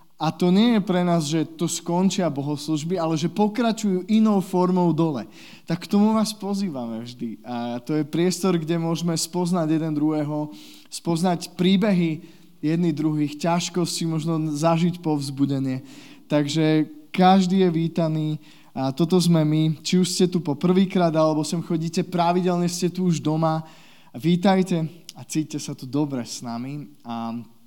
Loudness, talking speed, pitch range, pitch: -23 LUFS, 150 wpm, 155-180 Hz, 165 Hz